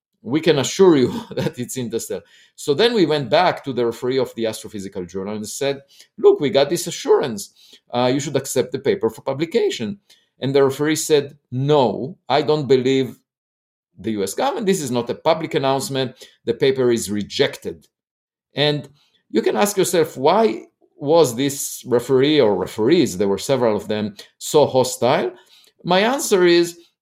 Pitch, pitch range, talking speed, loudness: 140 Hz, 125-170 Hz, 175 wpm, -19 LUFS